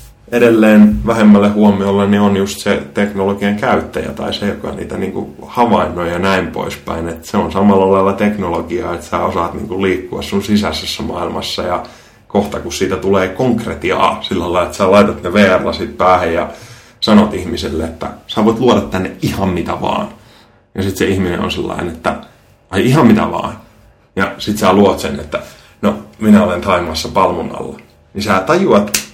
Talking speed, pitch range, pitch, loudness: 175 wpm, 90-105 Hz, 100 Hz, -14 LUFS